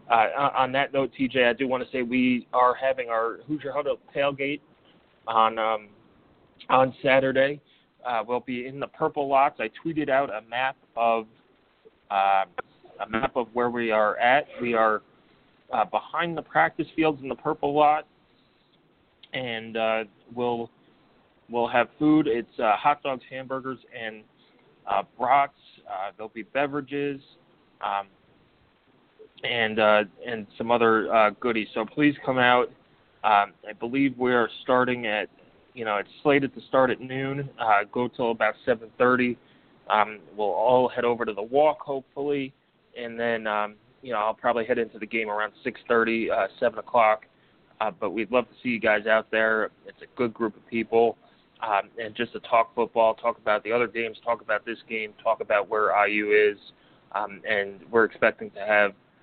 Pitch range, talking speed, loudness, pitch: 110-135 Hz, 170 wpm, -25 LUFS, 120 Hz